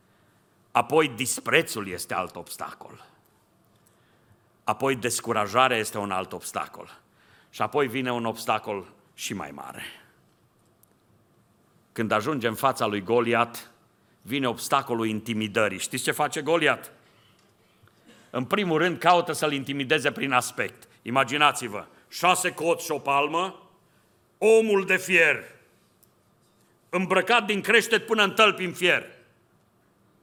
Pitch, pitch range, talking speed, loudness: 135 Hz, 115-170 Hz, 115 wpm, -24 LUFS